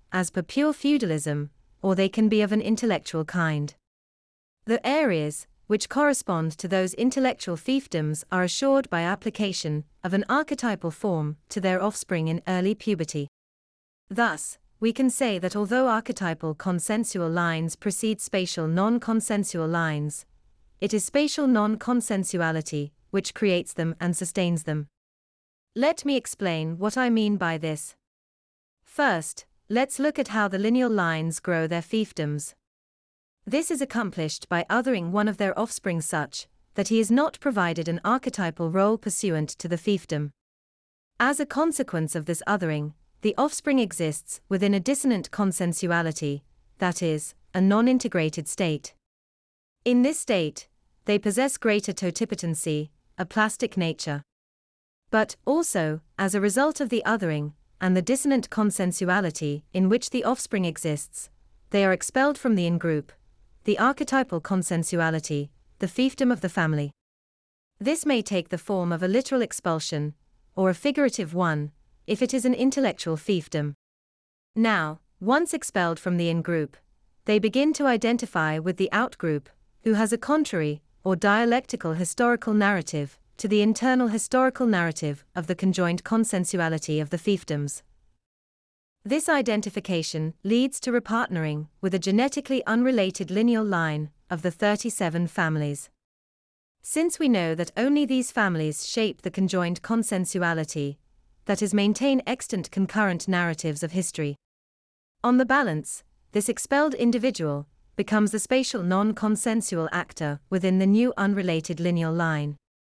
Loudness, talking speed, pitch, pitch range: -25 LUFS, 140 wpm, 185 Hz, 160-225 Hz